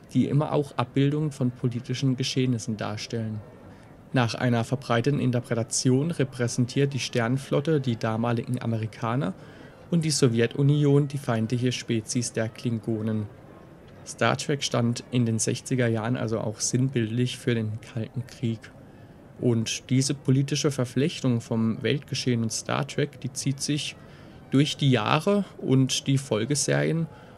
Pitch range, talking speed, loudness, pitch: 115-140 Hz, 125 wpm, -26 LUFS, 125 Hz